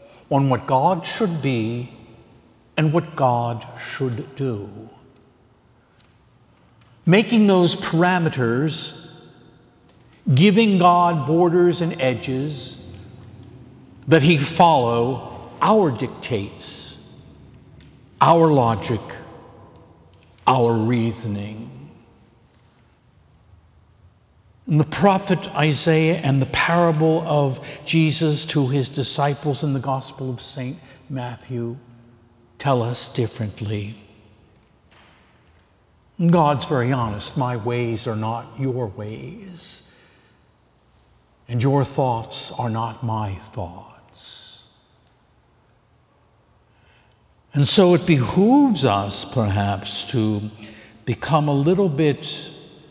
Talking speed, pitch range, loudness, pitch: 85 wpm, 115-155 Hz, -20 LUFS, 130 Hz